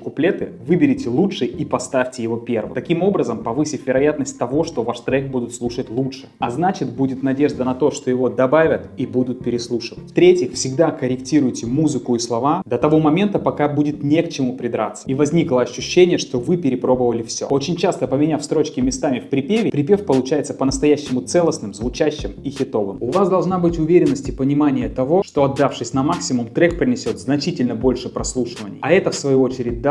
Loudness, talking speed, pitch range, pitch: -19 LUFS, 180 wpm, 125-155 Hz, 135 Hz